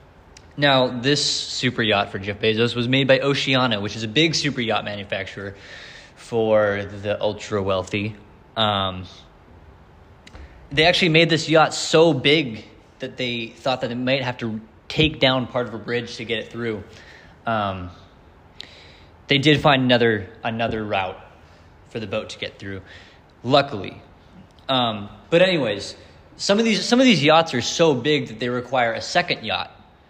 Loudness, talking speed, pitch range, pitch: -20 LUFS, 160 wpm, 95-135 Hz, 115 Hz